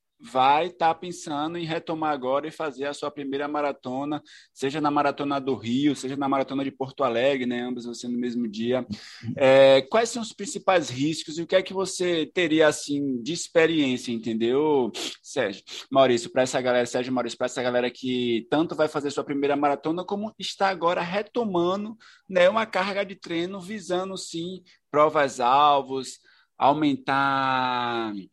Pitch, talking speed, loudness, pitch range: 145 Hz, 165 wpm, -25 LUFS, 130-175 Hz